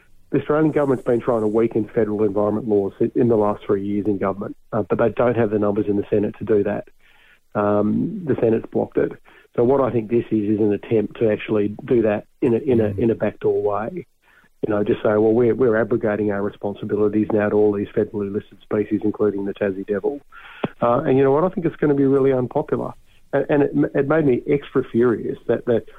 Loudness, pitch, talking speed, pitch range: -20 LUFS, 110 Hz, 230 wpm, 105-120 Hz